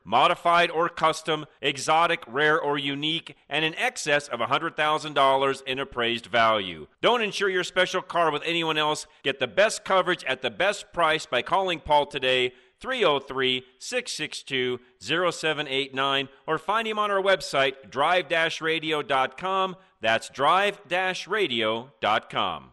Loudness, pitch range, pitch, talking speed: -25 LUFS, 135-175 Hz, 155 Hz, 130 wpm